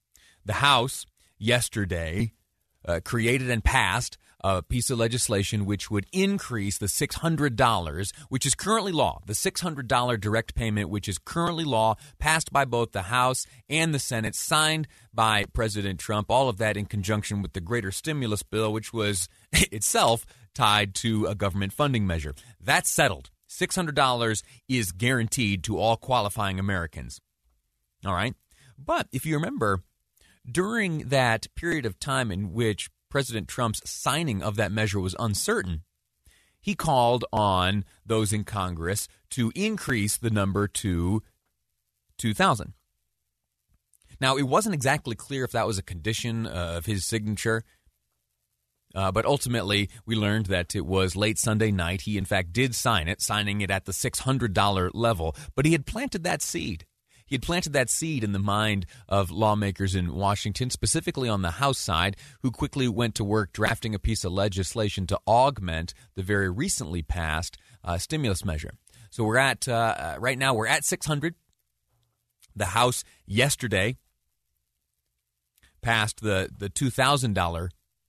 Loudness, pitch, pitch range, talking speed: -26 LUFS, 110 Hz, 95-125 Hz, 150 wpm